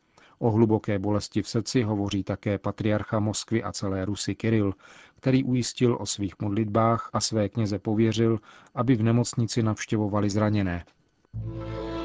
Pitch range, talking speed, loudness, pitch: 100-115 Hz, 135 wpm, -26 LUFS, 110 Hz